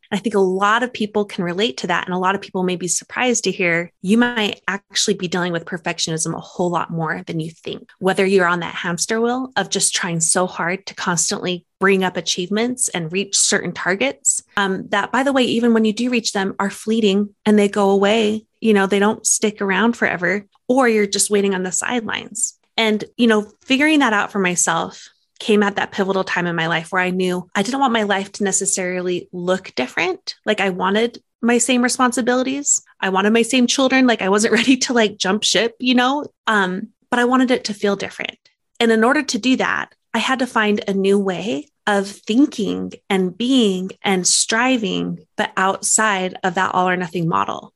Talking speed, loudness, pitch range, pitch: 210 wpm, -18 LUFS, 185-235 Hz, 205 Hz